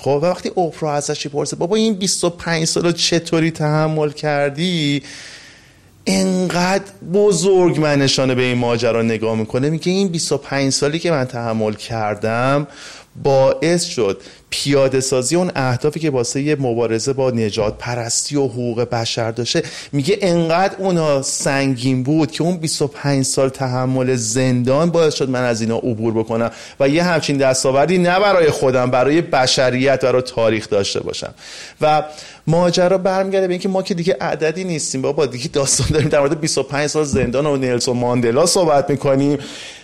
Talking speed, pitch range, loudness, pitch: 155 wpm, 125-165 Hz, -17 LUFS, 140 Hz